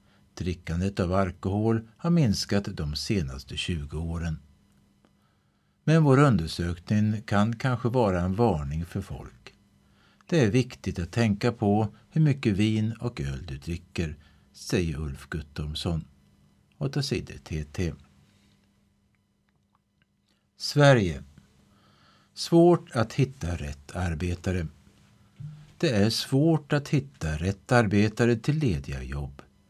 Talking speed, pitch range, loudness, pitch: 105 wpm, 80-120 Hz, -27 LUFS, 100 Hz